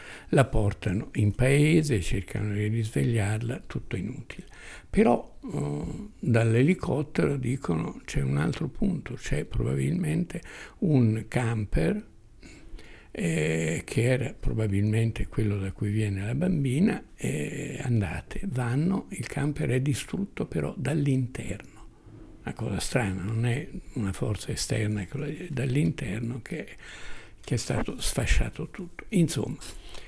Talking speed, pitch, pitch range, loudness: 115 wpm, 120 Hz, 105-145 Hz, -28 LUFS